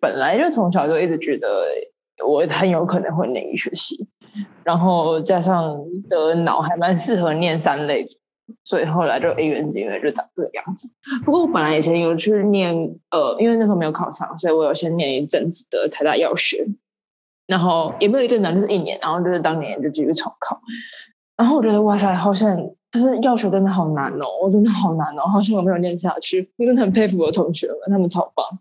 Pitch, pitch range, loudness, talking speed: 190 Hz, 170-220 Hz, -19 LUFS, 320 characters per minute